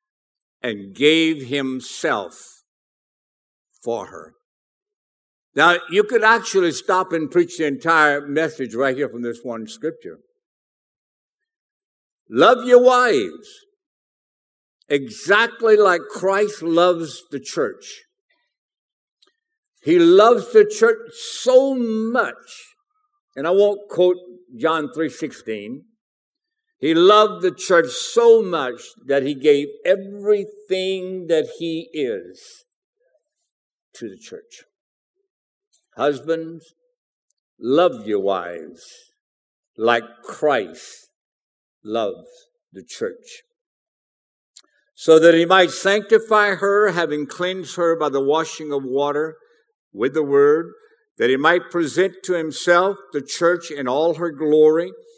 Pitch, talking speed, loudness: 200 Hz, 105 wpm, -18 LUFS